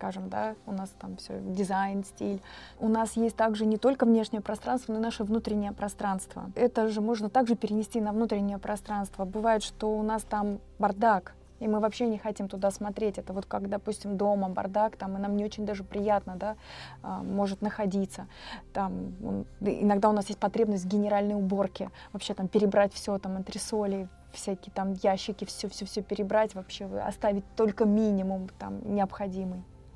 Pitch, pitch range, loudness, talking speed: 205 Hz, 195-215 Hz, -30 LUFS, 170 wpm